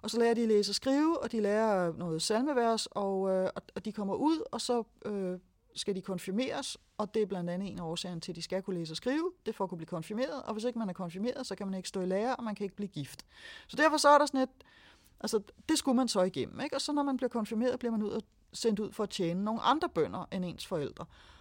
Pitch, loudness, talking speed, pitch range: 215 Hz, -33 LUFS, 280 wpm, 185-250 Hz